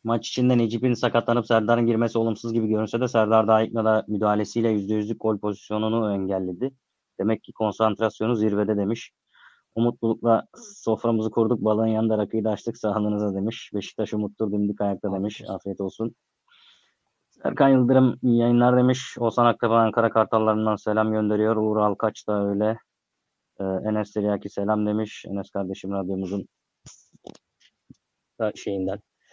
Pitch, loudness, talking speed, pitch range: 110 Hz, -24 LUFS, 135 wpm, 105-115 Hz